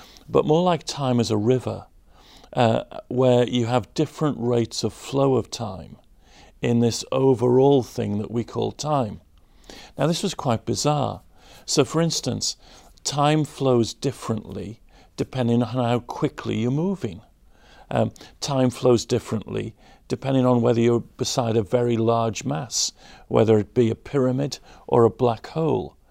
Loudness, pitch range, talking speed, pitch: -23 LUFS, 115-135 Hz, 145 wpm, 120 Hz